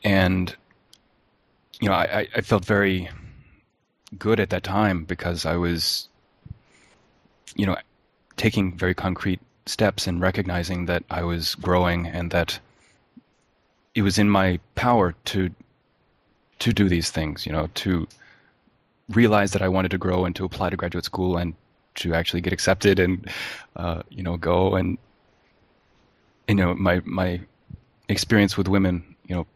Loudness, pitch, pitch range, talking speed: -23 LUFS, 90 Hz, 90-100 Hz, 150 wpm